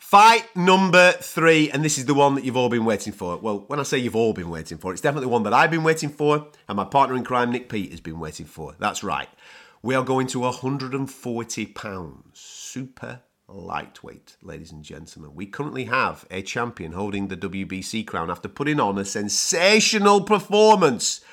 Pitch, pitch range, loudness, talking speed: 125 Hz, 100-150 Hz, -21 LUFS, 195 wpm